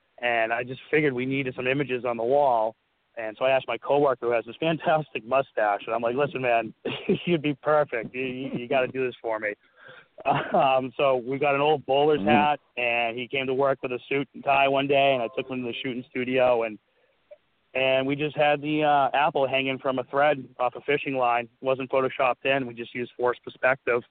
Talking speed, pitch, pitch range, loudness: 225 wpm, 130 Hz, 125-140 Hz, -25 LUFS